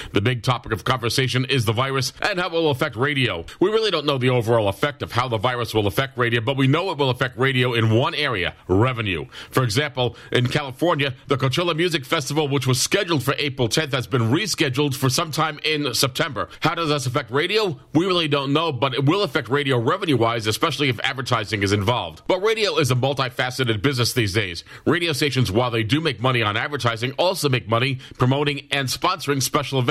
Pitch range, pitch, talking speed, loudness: 125-150 Hz, 135 Hz, 215 wpm, -21 LUFS